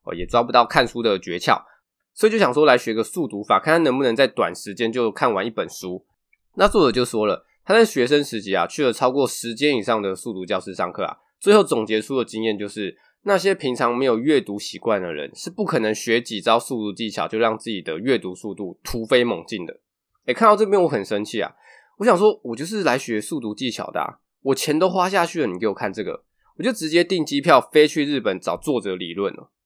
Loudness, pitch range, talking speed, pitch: -21 LUFS, 105-150 Hz, 335 characters per minute, 115 Hz